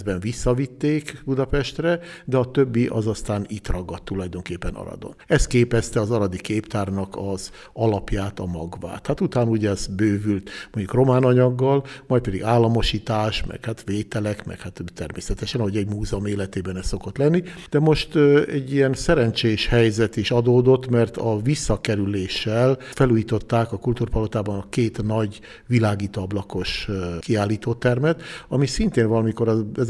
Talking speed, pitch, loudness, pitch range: 135 wpm, 110 Hz, -22 LUFS, 100-125 Hz